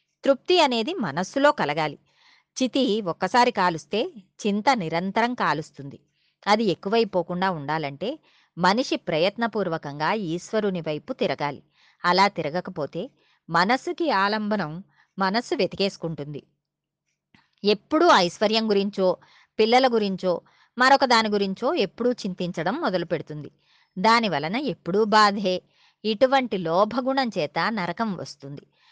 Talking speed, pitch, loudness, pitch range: 90 wpm, 195 Hz, -23 LUFS, 170-230 Hz